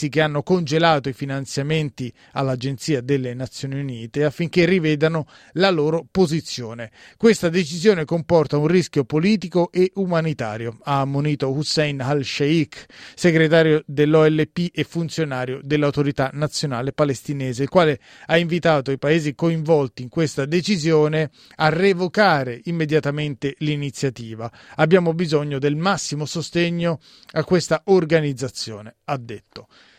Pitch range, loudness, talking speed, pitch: 140-165 Hz, -20 LUFS, 115 wpm, 150 Hz